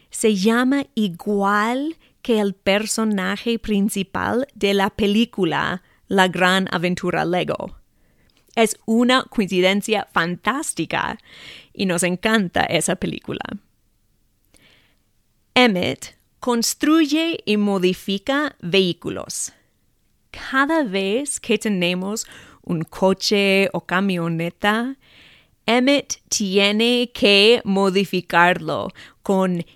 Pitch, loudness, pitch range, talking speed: 205 Hz, -20 LUFS, 185-230 Hz, 85 wpm